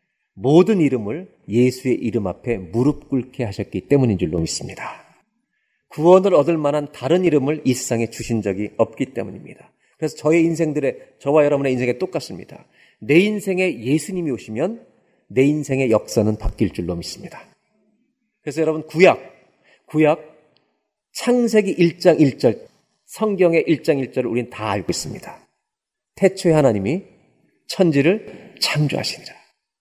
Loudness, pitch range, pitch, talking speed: -19 LUFS, 120-170 Hz, 145 Hz, 300 characters per minute